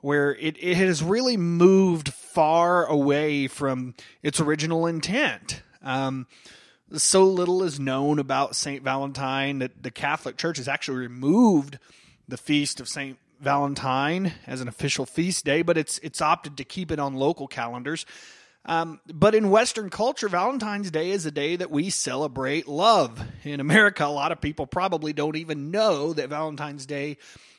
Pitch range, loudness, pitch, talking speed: 140-175 Hz, -24 LUFS, 150 Hz, 160 wpm